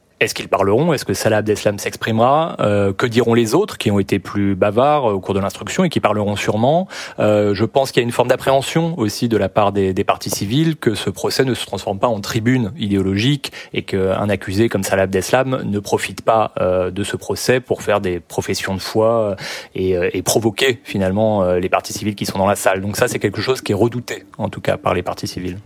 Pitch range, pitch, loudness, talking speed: 100-120 Hz, 105 Hz, -18 LUFS, 230 wpm